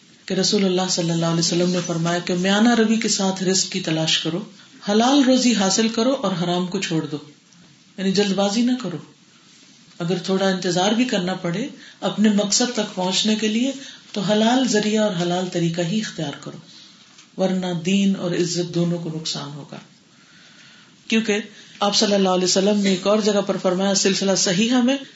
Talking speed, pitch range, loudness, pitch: 180 wpm, 180-215 Hz, -20 LUFS, 195 Hz